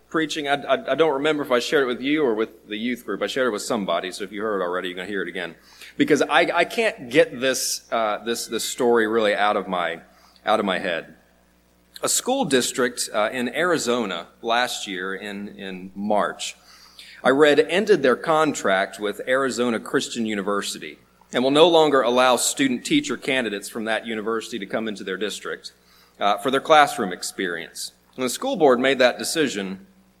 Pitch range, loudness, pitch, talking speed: 100-135 Hz, -22 LUFS, 115 Hz, 195 wpm